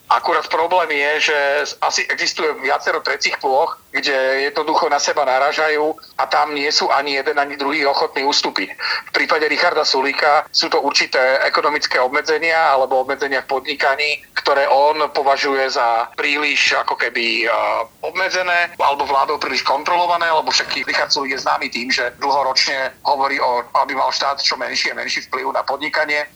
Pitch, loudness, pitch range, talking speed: 145 Hz, -17 LUFS, 135-155 Hz, 160 wpm